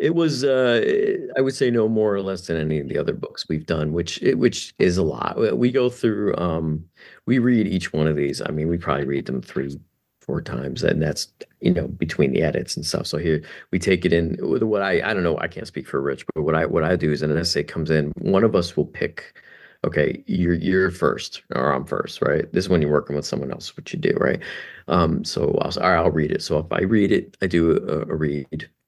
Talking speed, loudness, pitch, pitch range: 250 wpm, -22 LUFS, 85 Hz, 75-105 Hz